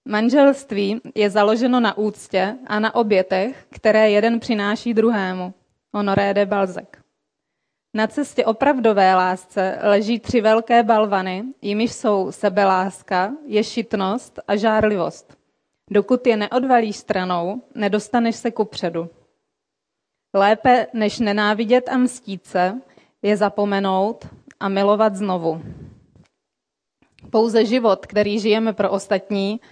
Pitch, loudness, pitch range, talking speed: 210 Hz, -19 LUFS, 195-230 Hz, 110 wpm